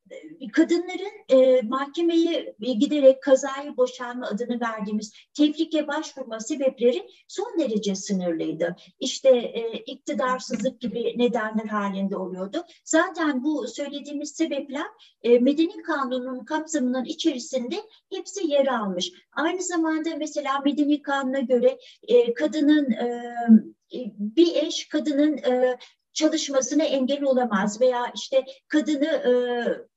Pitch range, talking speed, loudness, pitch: 245-310 Hz, 105 wpm, -24 LUFS, 270 Hz